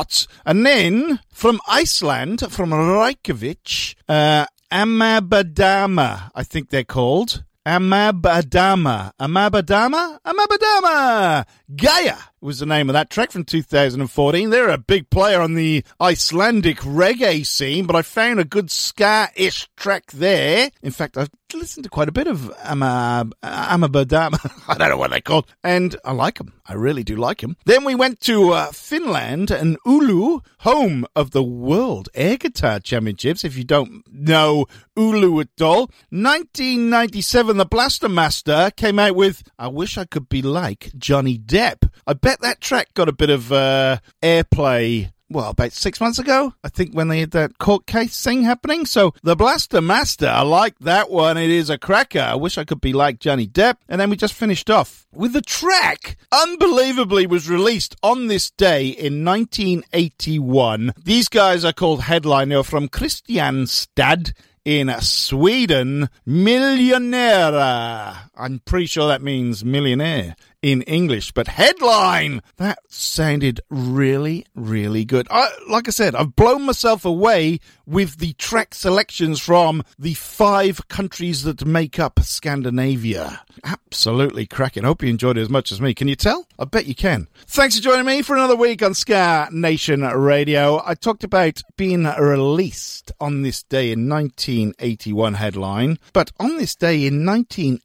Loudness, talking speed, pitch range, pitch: -17 LUFS, 155 wpm, 135-205 Hz, 165 Hz